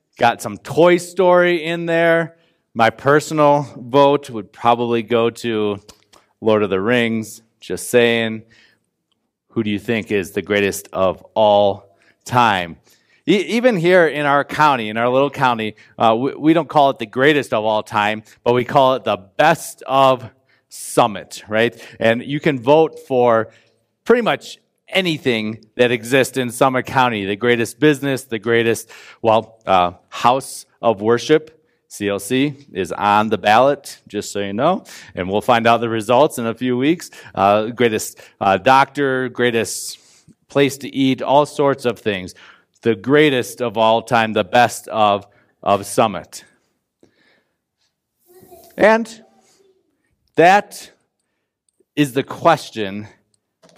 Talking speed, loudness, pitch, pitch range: 145 wpm, -17 LUFS, 120 Hz, 110-145 Hz